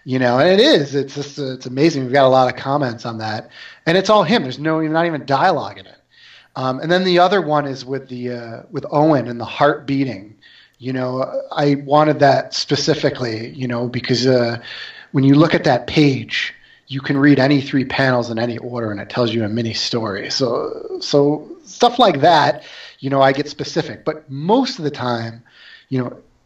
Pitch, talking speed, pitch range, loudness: 135 Hz, 215 wpm, 125-150 Hz, -17 LUFS